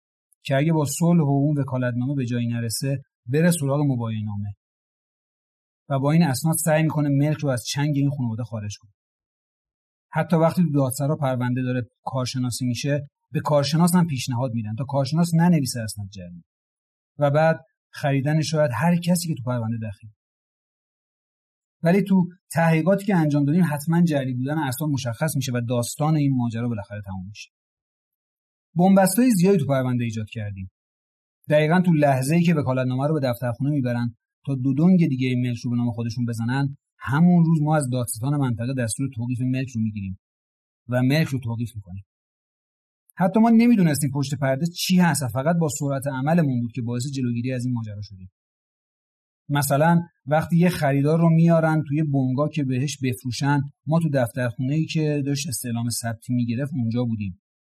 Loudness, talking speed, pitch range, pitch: -22 LUFS, 170 wpm, 120-155 Hz, 135 Hz